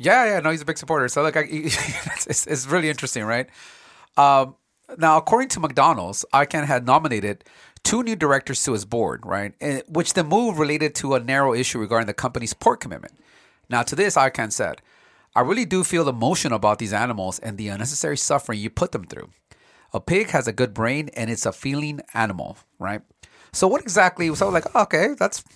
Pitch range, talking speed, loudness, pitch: 115-160 Hz, 200 wpm, -21 LUFS, 140 Hz